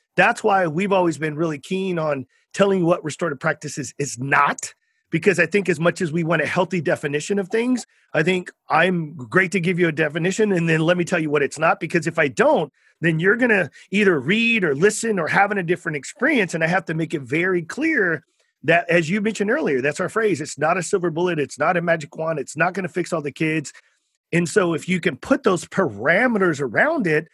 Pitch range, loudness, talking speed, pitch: 160-195 Hz, -20 LUFS, 235 wpm, 175 Hz